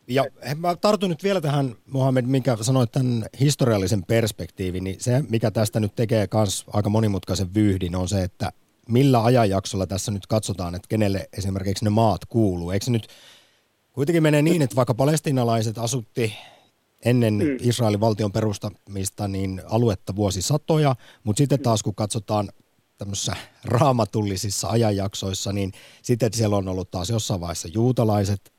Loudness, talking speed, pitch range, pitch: -23 LUFS, 145 wpm, 100-125 Hz, 110 Hz